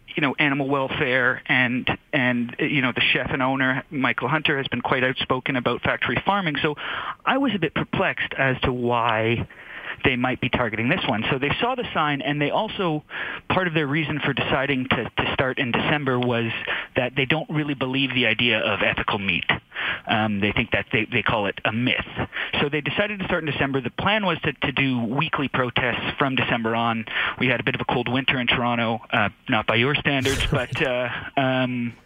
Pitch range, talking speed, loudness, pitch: 125-150 Hz, 210 wpm, -22 LUFS, 135 Hz